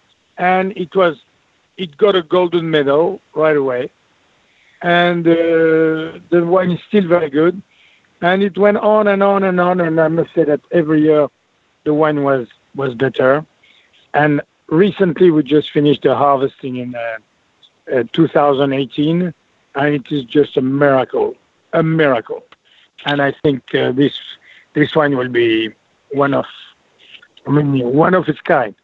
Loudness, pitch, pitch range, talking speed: -15 LUFS, 155 Hz, 140-175 Hz, 155 wpm